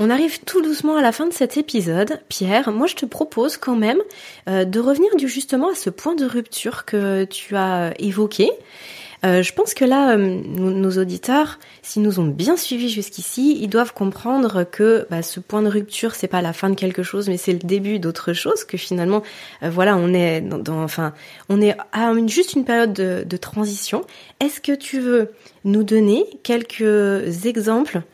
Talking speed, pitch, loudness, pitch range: 190 wpm, 215 Hz, -19 LUFS, 190-255 Hz